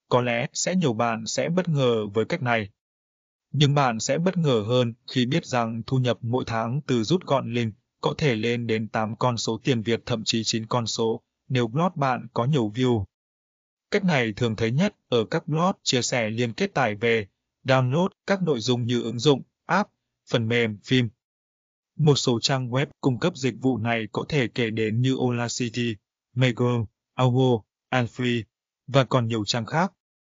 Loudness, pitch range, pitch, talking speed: -24 LUFS, 115-135 Hz, 120 Hz, 190 wpm